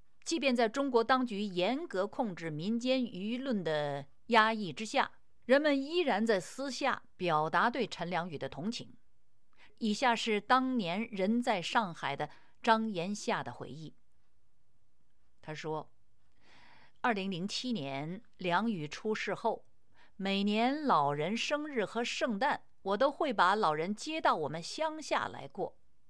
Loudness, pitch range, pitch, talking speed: -33 LUFS, 175-250 Hz, 220 Hz, 200 characters per minute